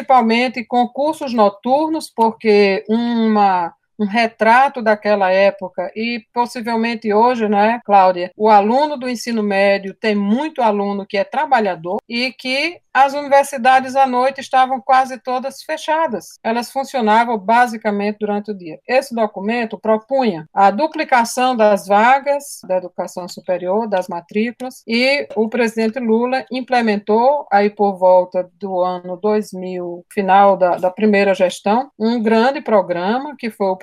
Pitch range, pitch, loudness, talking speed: 200-255 Hz, 225 Hz, -16 LUFS, 135 wpm